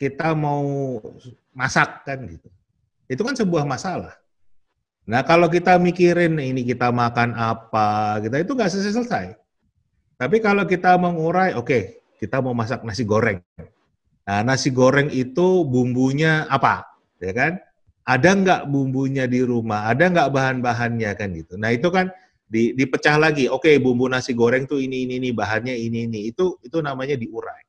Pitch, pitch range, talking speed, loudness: 130 Hz, 120-165 Hz, 155 wpm, -20 LUFS